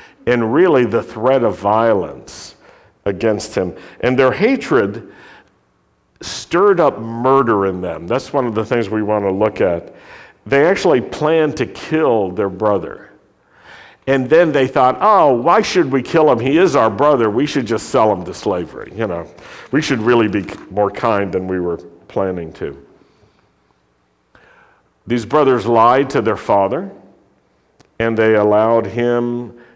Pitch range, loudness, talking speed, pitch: 100-130 Hz, -15 LUFS, 155 wpm, 115 Hz